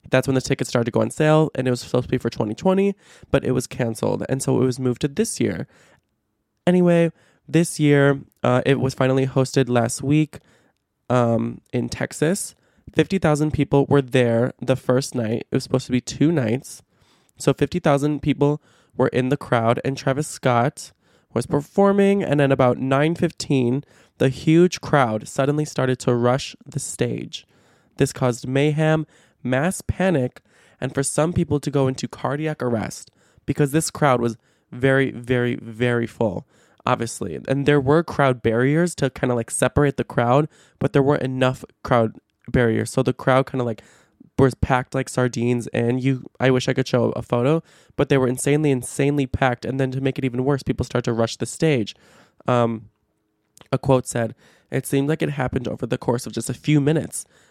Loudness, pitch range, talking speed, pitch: -21 LUFS, 125-145 Hz, 185 wpm, 130 Hz